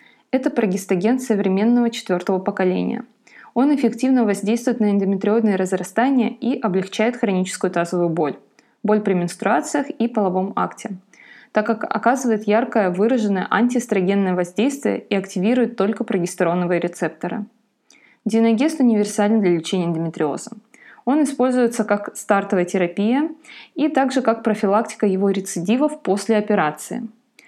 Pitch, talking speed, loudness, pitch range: 215 Hz, 115 wpm, -20 LUFS, 190-240 Hz